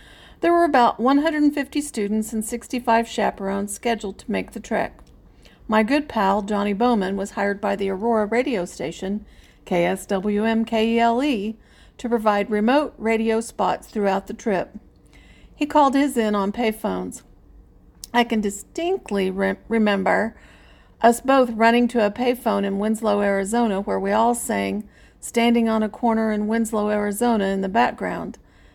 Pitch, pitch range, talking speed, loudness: 220 Hz, 205-240 Hz, 140 wpm, -21 LUFS